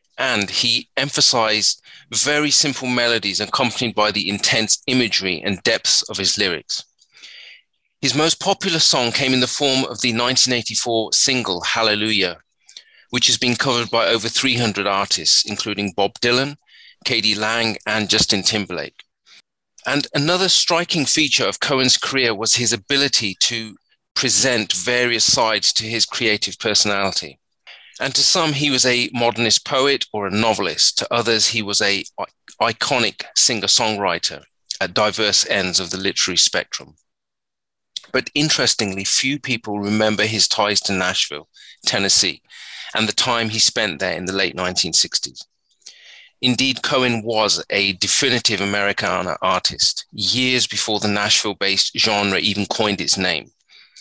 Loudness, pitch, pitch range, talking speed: -17 LUFS, 115 Hz, 105-130 Hz, 140 wpm